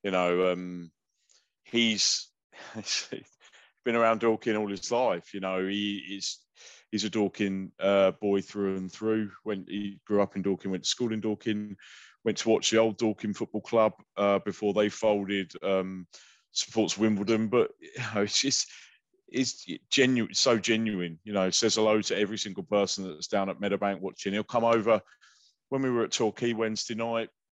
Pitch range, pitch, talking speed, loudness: 95-110 Hz, 105 Hz, 175 wpm, -28 LUFS